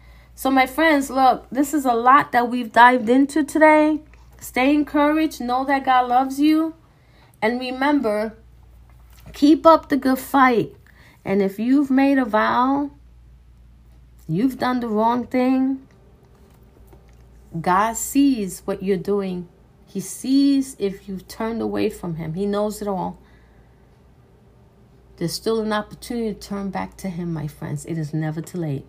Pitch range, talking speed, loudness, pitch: 170-265 Hz, 145 wpm, -20 LUFS, 225 Hz